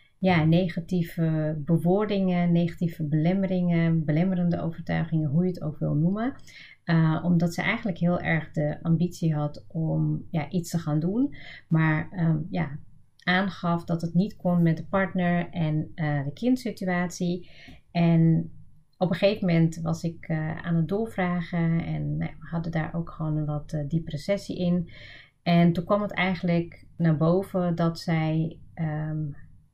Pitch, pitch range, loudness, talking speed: 170 Hz, 155-180 Hz, -26 LUFS, 155 wpm